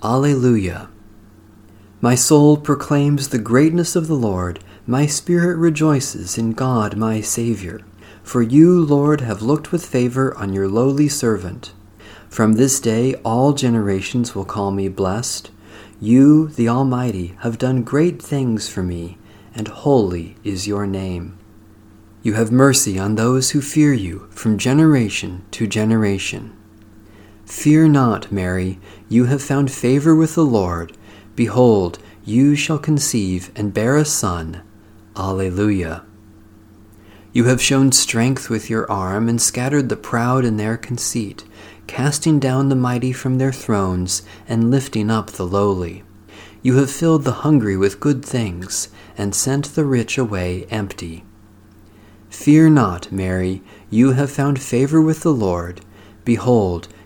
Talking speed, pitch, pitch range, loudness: 140 wpm, 110 Hz, 105-135 Hz, -17 LUFS